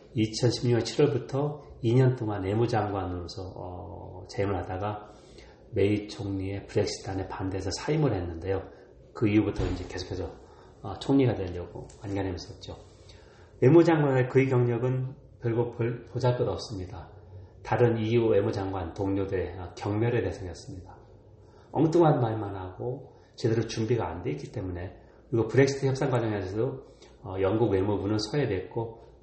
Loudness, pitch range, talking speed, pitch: -28 LUFS, 95-120 Hz, 315 characters per minute, 110 Hz